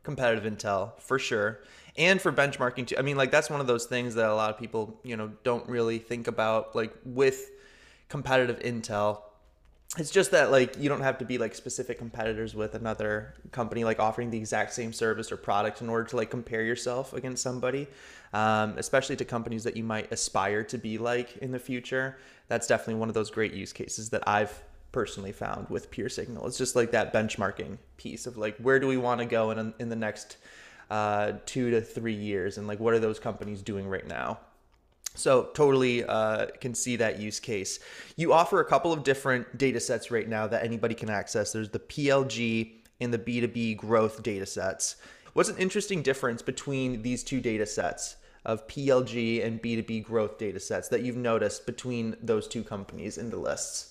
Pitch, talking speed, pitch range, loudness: 115 Hz, 200 wpm, 110-125 Hz, -29 LUFS